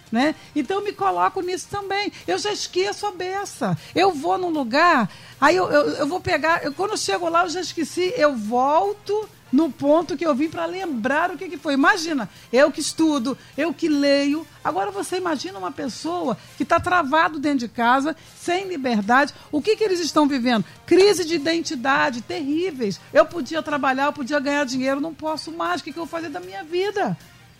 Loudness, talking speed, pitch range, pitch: -22 LUFS, 200 wpm, 290-360 Hz, 320 Hz